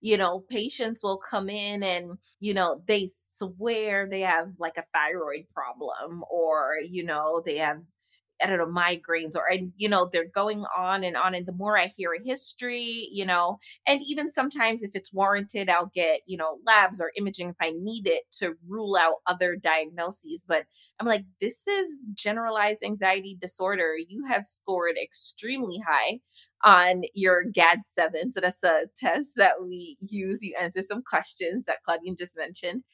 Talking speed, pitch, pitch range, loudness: 180 wpm, 195 Hz, 175-215 Hz, -26 LUFS